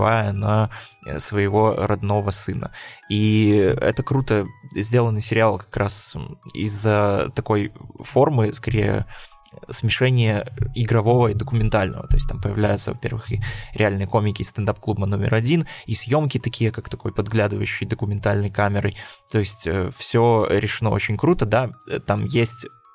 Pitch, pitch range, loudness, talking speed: 110 Hz, 105-115 Hz, -21 LUFS, 125 wpm